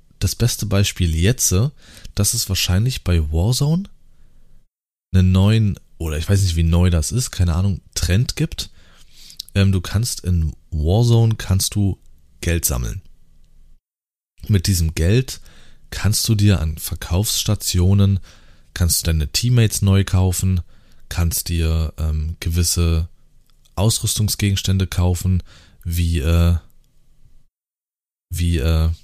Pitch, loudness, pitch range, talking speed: 95 Hz, -19 LUFS, 85-105 Hz, 115 wpm